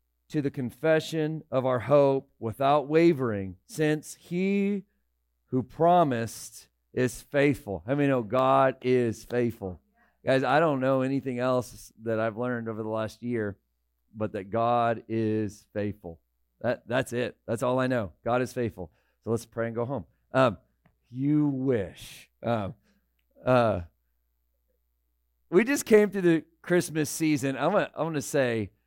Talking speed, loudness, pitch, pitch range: 150 wpm, -27 LUFS, 120 Hz, 105-140 Hz